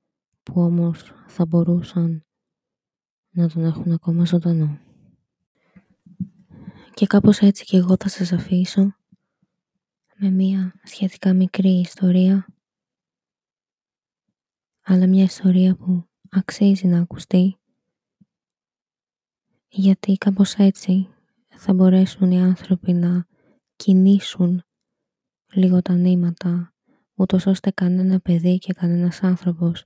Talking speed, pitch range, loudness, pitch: 95 wpm, 175-195 Hz, -19 LUFS, 185 Hz